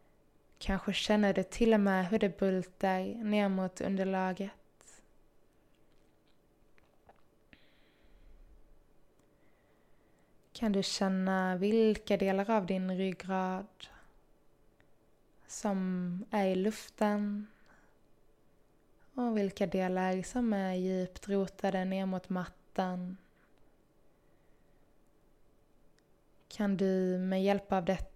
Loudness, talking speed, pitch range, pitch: -33 LUFS, 85 wpm, 185-205 Hz, 195 Hz